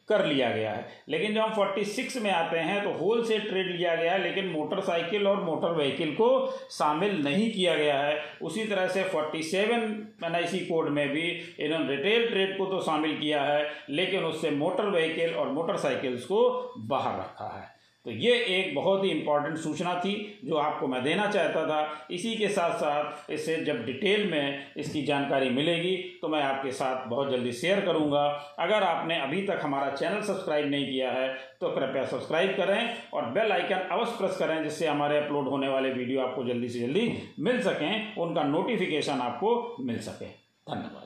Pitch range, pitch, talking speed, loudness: 145-195 Hz, 165 Hz, 190 wpm, -28 LUFS